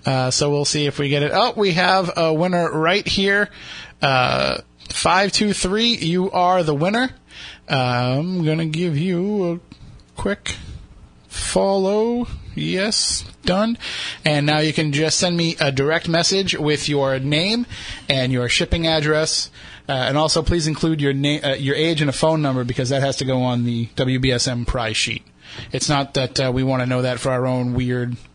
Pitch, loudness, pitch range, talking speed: 150 Hz, -19 LUFS, 130-175 Hz, 185 wpm